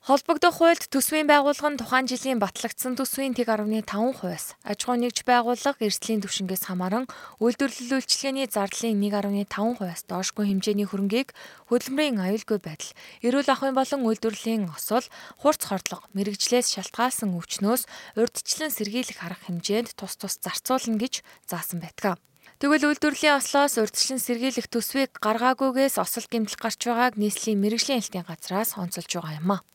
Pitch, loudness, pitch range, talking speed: 230 Hz, -25 LUFS, 205-265 Hz, 135 wpm